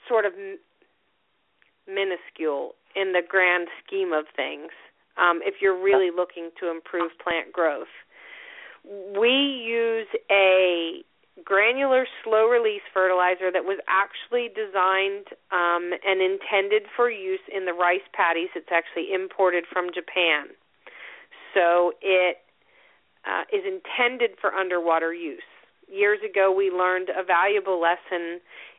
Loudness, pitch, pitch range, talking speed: -23 LUFS, 190 Hz, 180-260 Hz, 125 wpm